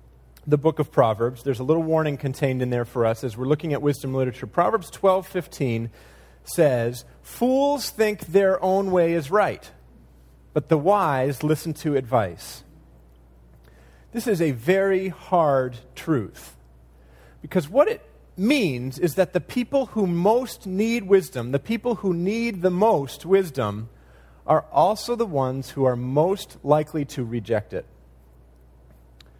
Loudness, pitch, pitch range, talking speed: -23 LUFS, 145 Hz, 115-190 Hz, 145 wpm